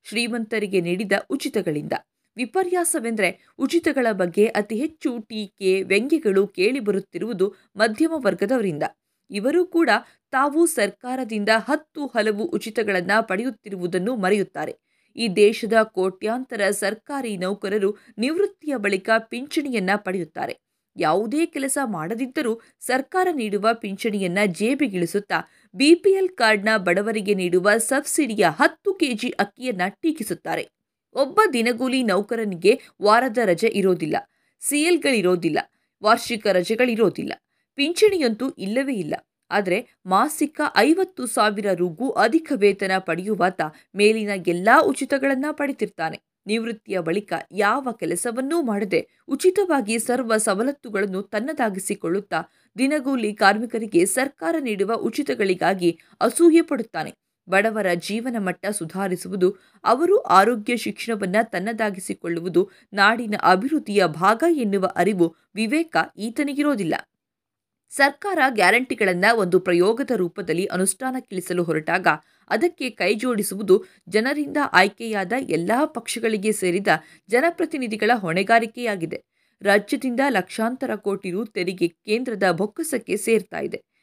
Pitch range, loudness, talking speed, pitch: 195-270 Hz, -22 LUFS, 90 wpm, 220 Hz